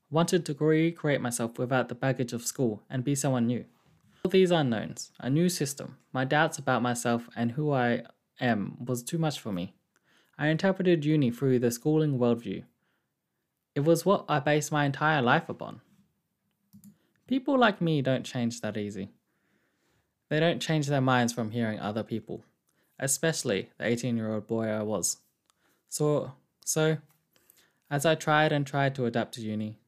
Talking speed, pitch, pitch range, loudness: 165 wpm, 140 Hz, 120-160 Hz, -28 LUFS